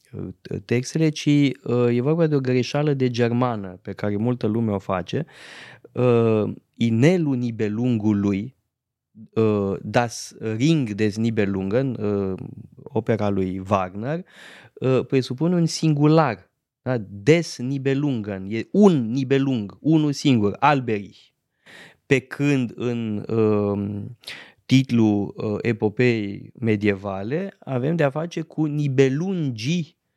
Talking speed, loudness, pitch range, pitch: 105 wpm, -22 LUFS, 105-140 Hz, 120 Hz